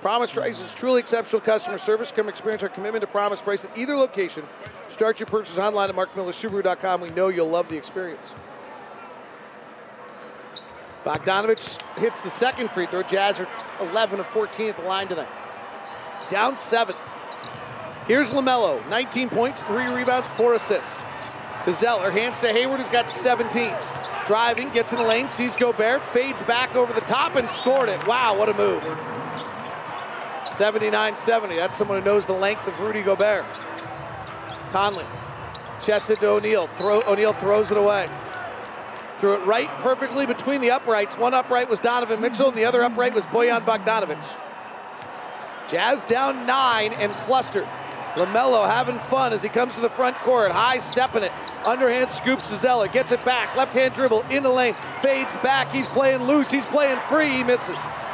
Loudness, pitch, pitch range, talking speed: -22 LUFS, 230 Hz, 205-250 Hz, 165 wpm